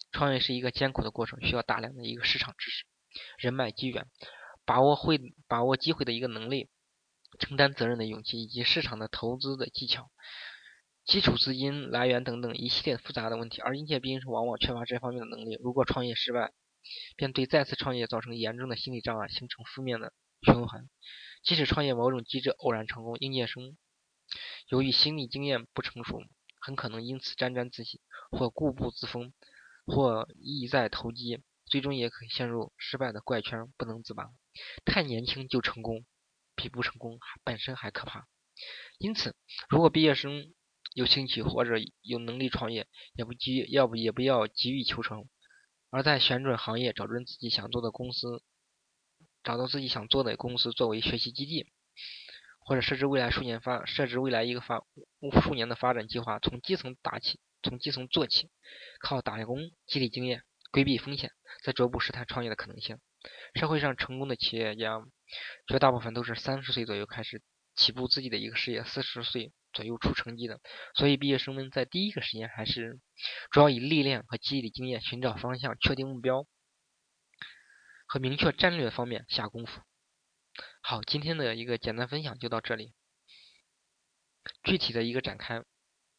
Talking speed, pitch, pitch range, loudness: 280 characters per minute, 125 Hz, 115-135 Hz, -31 LUFS